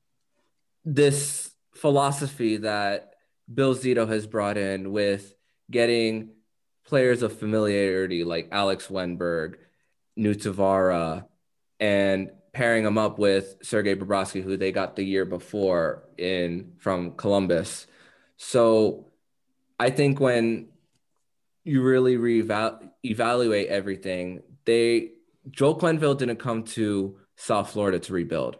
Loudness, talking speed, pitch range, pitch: -25 LUFS, 110 wpm, 95-120 Hz, 105 Hz